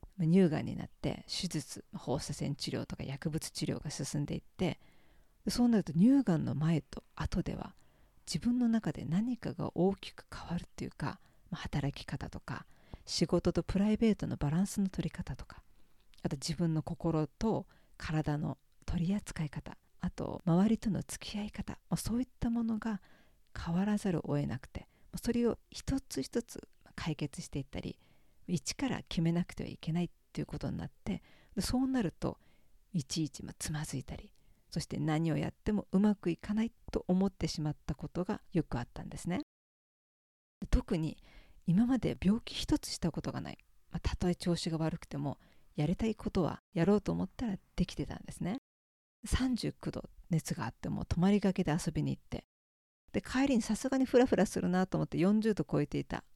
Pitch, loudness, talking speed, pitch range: 175 Hz, -35 LUFS, 335 characters per minute, 155-210 Hz